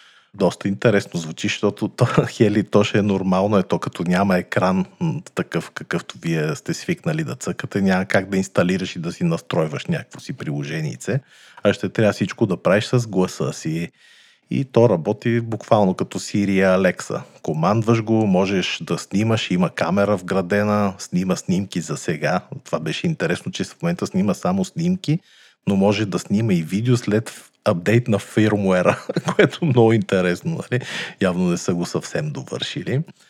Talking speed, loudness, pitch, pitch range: 165 wpm, -21 LUFS, 105 Hz, 95-155 Hz